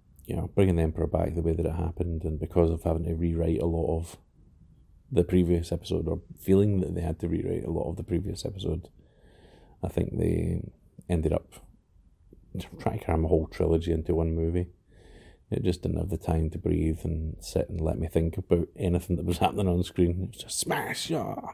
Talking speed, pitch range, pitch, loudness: 210 wpm, 80-90 Hz, 85 Hz, -29 LUFS